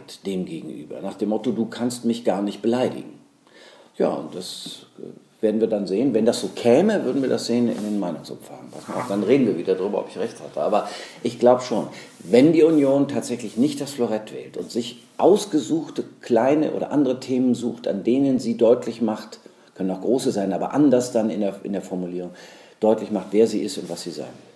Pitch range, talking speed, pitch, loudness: 100-125 Hz, 205 wpm, 115 Hz, -22 LUFS